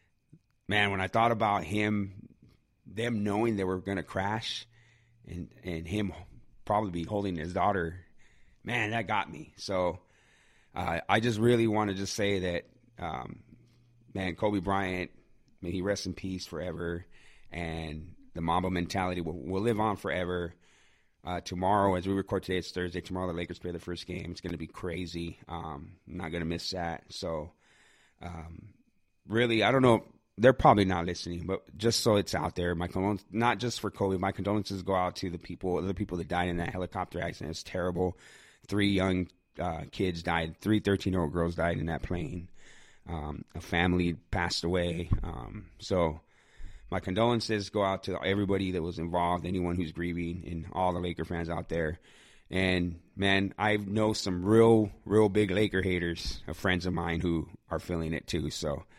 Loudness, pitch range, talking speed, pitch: -31 LUFS, 85-100 Hz, 185 wpm, 90 Hz